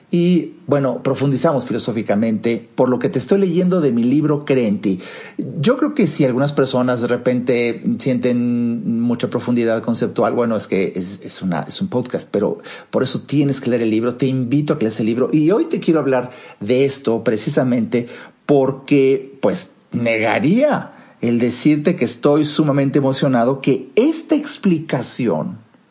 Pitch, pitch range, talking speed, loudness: 135 Hz, 120-155 Hz, 165 wpm, -18 LUFS